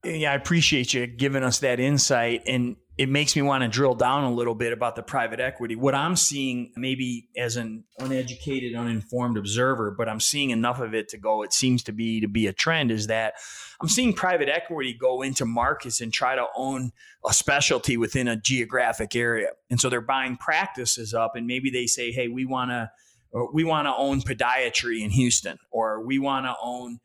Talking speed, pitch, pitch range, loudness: 210 wpm, 125 Hz, 115-135 Hz, -24 LUFS